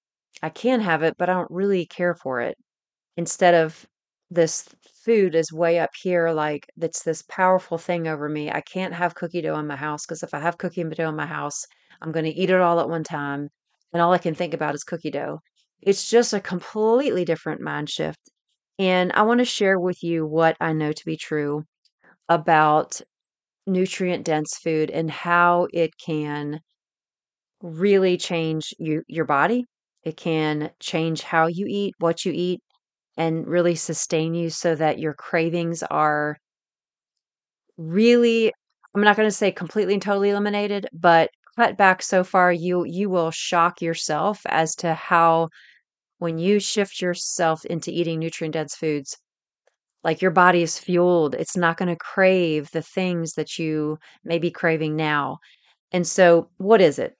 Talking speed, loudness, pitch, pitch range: 175 wpm, -22 LUFS, 170 Hz, 160-185 Hz